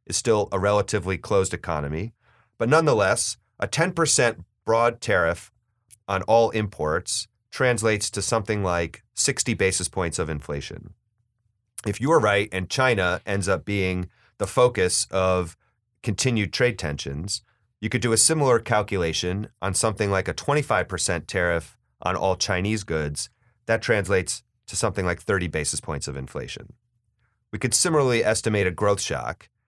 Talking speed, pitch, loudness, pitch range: 145 wpm, 105 Hz, -23 LUFS, 90-115 Hz